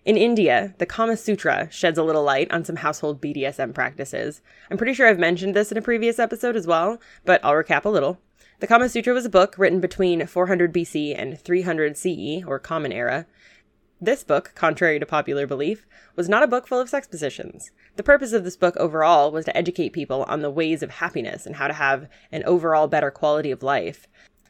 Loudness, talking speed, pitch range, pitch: -21 LUFS, 210 wpm, 150-210 Hz, 175 Hz